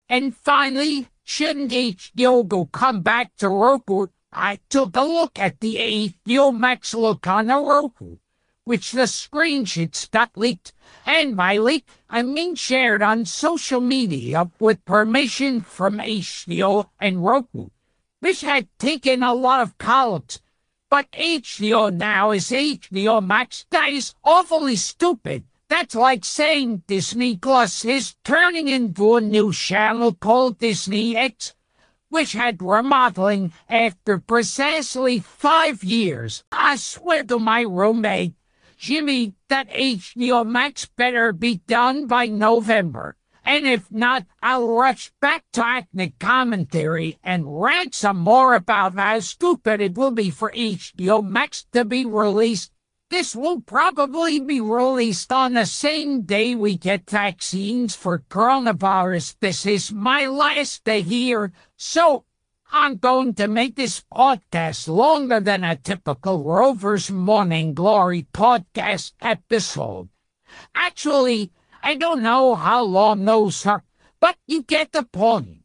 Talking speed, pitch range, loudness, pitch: 130 wpm, 200-265 Hz, -19 LUFS, 230 Hz